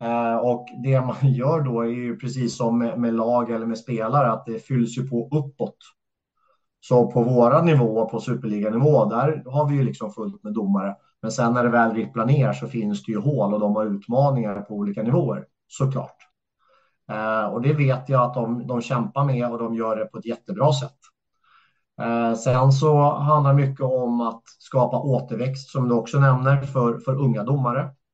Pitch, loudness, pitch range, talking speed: 120 Hz, -22 LUFS, 115-135 Hz, 195 wpm